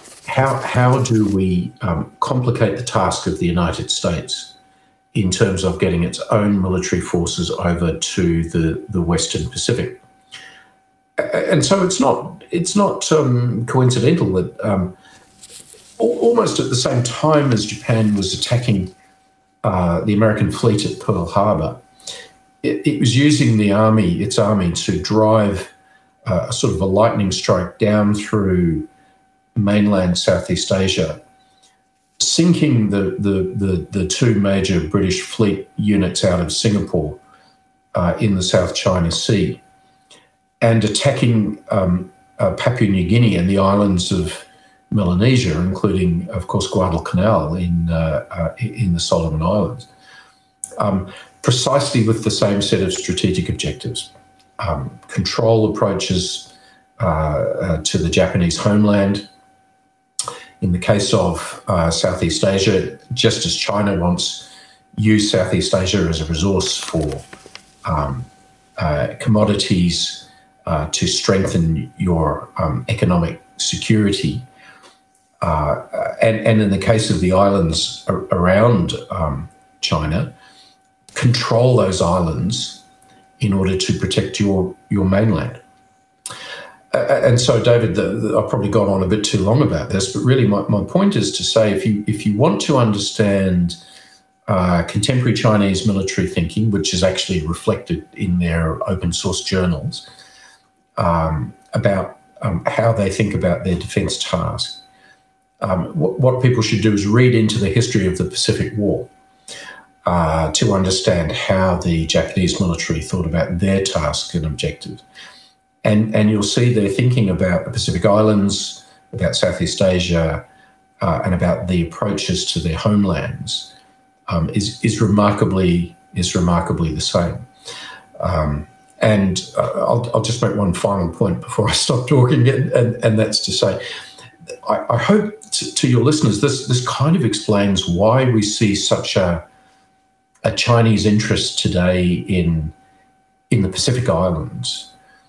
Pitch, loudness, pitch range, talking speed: 100 Hz, -17 LUFS, 90-115 Hz, 140 wpm